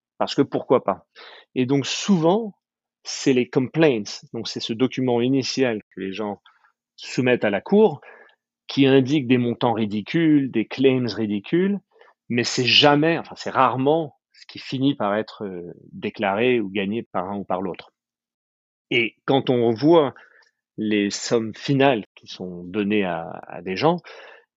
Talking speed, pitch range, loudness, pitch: 155 wpm, 105-145 Hz, -21 LUFS, 125 Hz